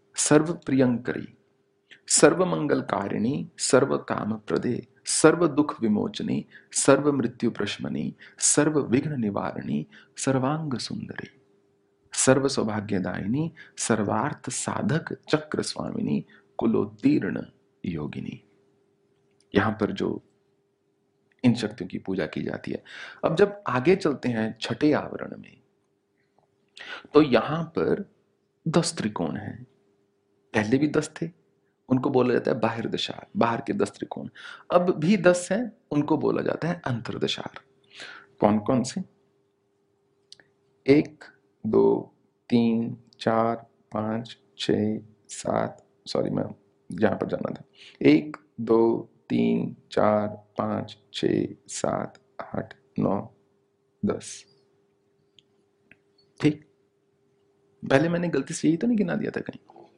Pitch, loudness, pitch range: 130 Hz, -26 LUFS, 105-155 Hz